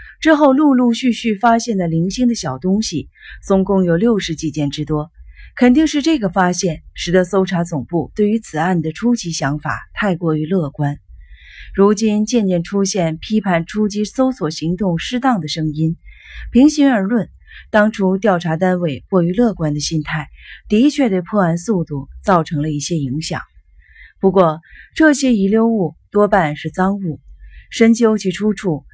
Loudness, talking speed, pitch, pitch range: -16 LUFS, 245 characters per minute, 185 Hz, 160-220 Hz